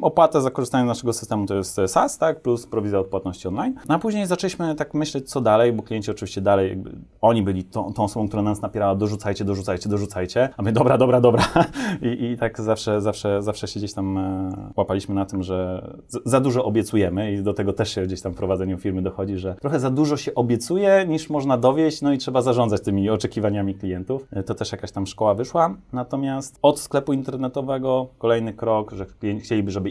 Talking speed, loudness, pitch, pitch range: 205 wpm, -22 LUFS, 110 Hz, 100-130 Hz